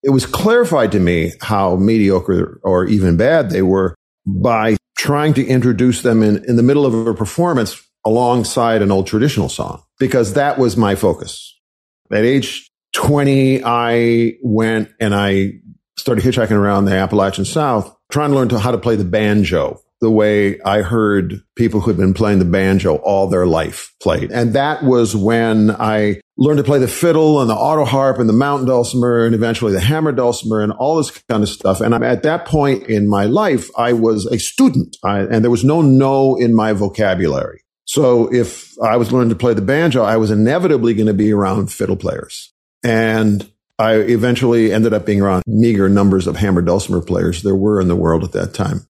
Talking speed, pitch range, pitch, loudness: 195 wpm, 100-125 Hz, 110 Hz, -15 LUFS